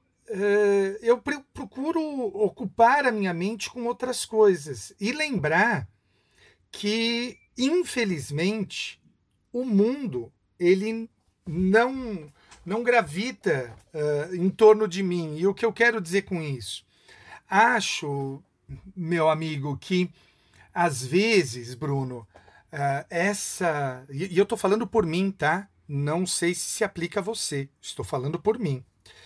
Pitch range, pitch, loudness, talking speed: 145-220 Hz, 185 Hz, -25 LUFS, 125 wpm